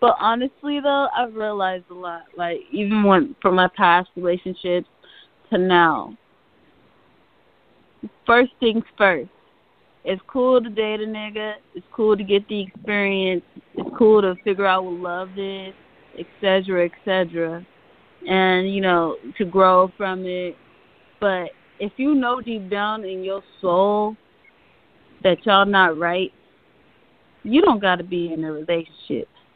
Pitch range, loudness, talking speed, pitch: 180-215 Hz, -20 LUFS, 140 wpm, 195 Hz